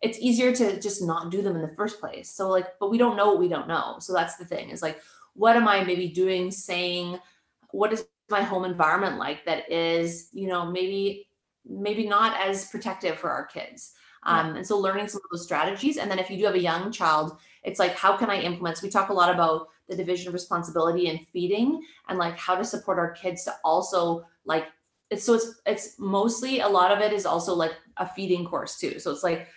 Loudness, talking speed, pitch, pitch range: -26 LUFS, 235 wpm, 190 Hz, 175-205 Hz